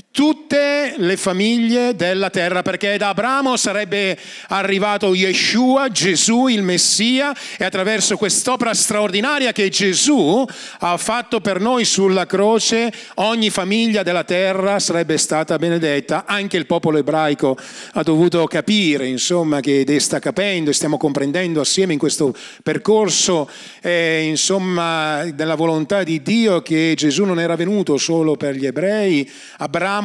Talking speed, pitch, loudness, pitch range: 135 wpm, 190 Hz, -17 LUFS, 160-210 Hz